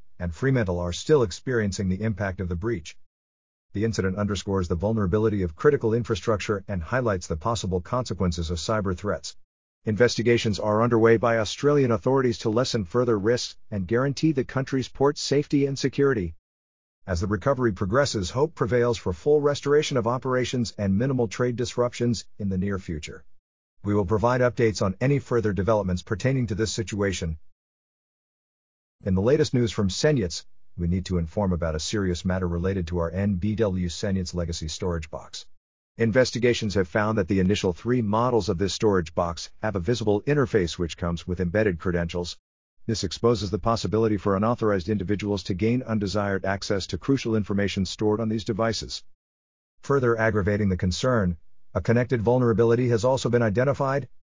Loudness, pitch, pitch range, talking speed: -25 LUFS, 105 Hz, 90-120 Hz, 160 wpm